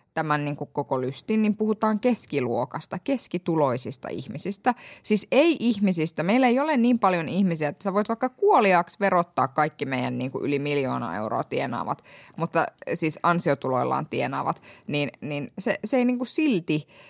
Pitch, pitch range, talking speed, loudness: 175 Hz, 145-230 Hz, 160 wpm, -25 LUFS